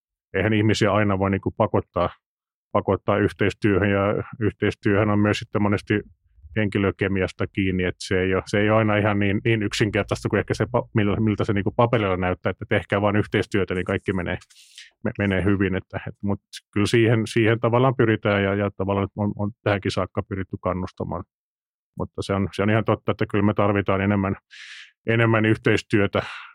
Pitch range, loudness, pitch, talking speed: 95-110 Hz, -23 LUFS, 105 Hz, 170 wpm